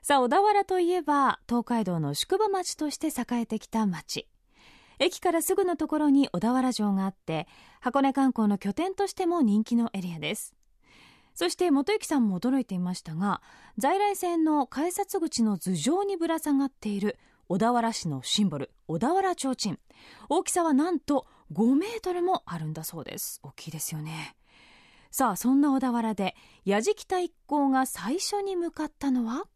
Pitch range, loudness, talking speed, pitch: 205-345 Hz, -27 LUFS, 330 characters per minute, 265 Hz